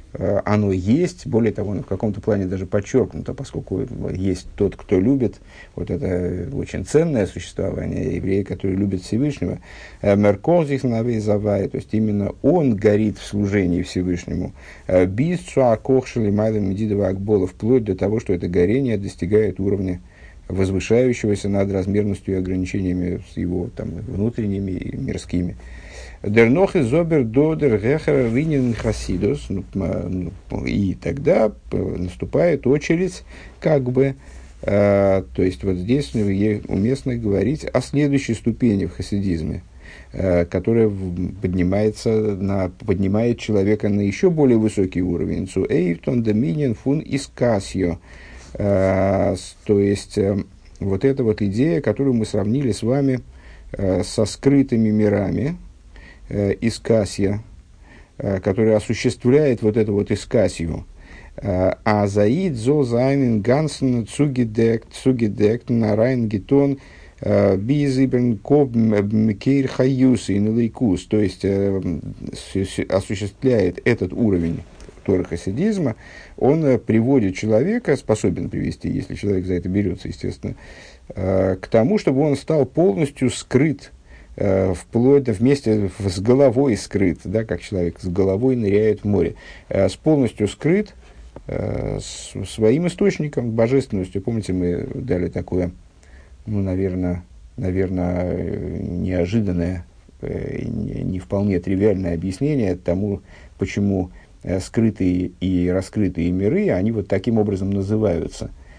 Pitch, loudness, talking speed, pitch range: 100 Hz, -20 LUFS, 110 wpm, 95-120 Hz